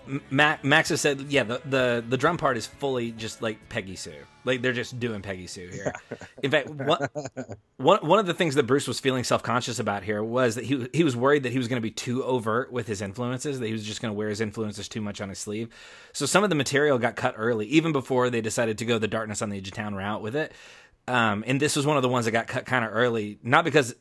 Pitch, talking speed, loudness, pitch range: 125 Hz, 270 wpm, -26 LUFS, 110-140 Hz